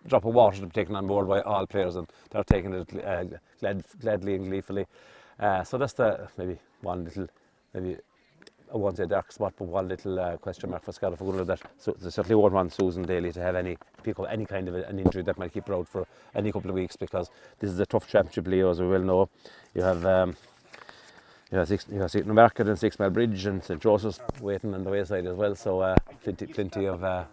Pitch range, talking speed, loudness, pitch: 90-100 Hz, 245 wpm, -28 LUFS, 95 Hz